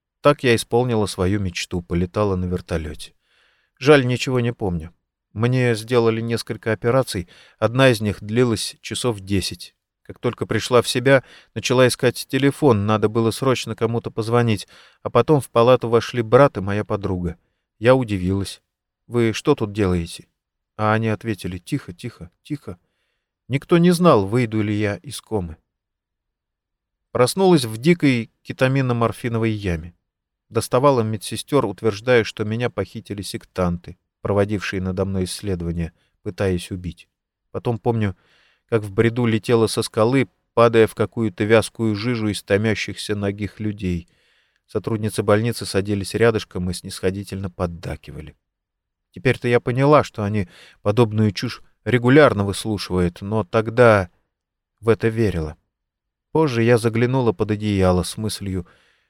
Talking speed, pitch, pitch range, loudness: 130 wpm, 110 Hz, 95-120 Hz, -20 LUFS